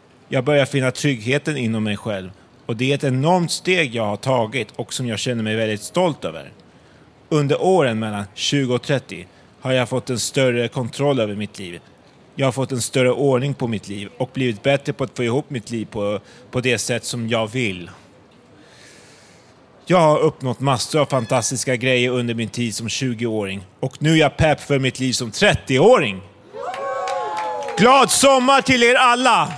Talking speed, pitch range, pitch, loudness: 185 wpm, 115-145 Hz, 130 Hz, -19 LUFS